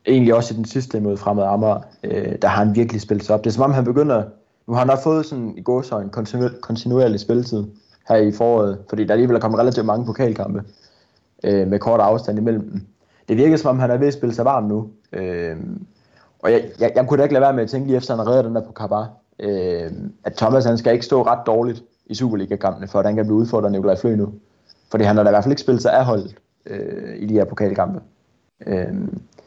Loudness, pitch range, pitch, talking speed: -19 LUFS, 105-125 Hz, 110 Hz, 250 wpm